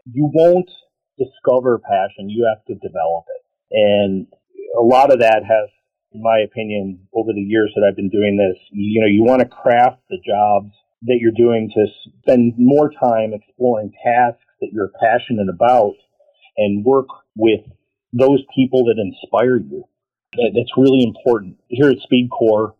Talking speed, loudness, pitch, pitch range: 160 wpm, -16 LUFS, 115 Hz, 105-130 Hz